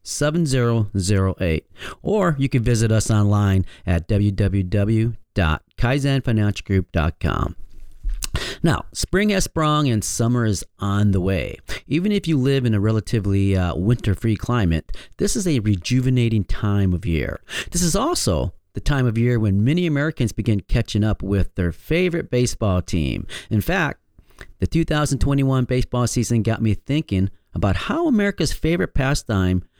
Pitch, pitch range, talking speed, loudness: 110 Hz, 95-135 Hz, 140 wpm, -21 LUFS